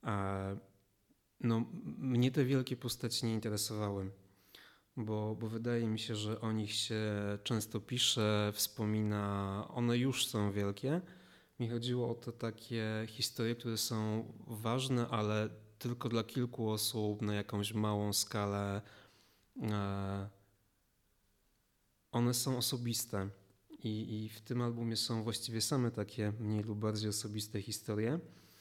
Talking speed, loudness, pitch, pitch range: 120 wpm, -37 LUFS, 110 Hz, 105-120 Hz